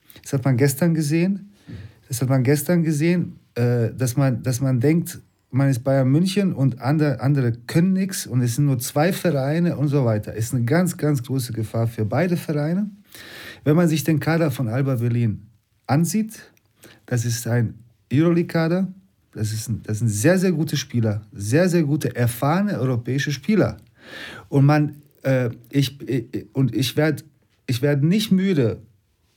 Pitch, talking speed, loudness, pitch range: 135 Hz, 160 wpm, -21 LUFS, 120-160 Hz